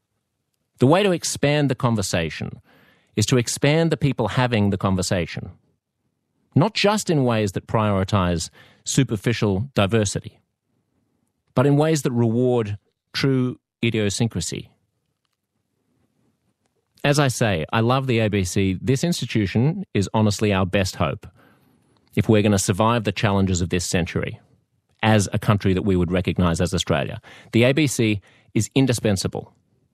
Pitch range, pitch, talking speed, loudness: 100-130 Hz, 110 Hz, 130 wpm, -21 LUFS